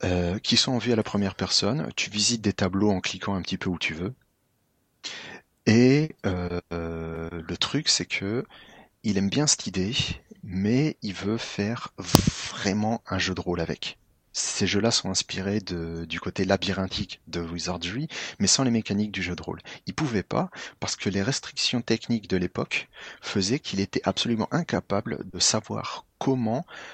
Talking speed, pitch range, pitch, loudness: 175 wpm, 90-115 Hz, 100 Hz, -26 LUFS